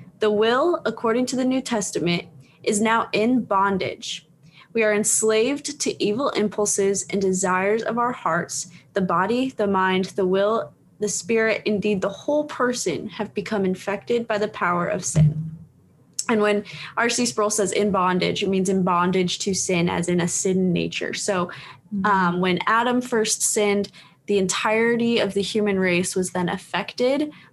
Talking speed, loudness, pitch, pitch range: 165 wpm, -22 LUFS, 200 Hz, 180-220 Hz